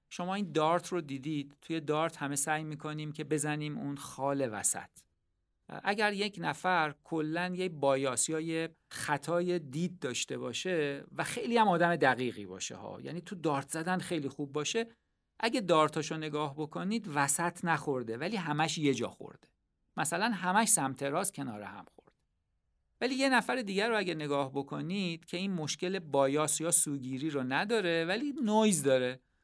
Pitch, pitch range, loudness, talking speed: 155 Hz, 140-180 Hz, -32 LUFS, 160 wpm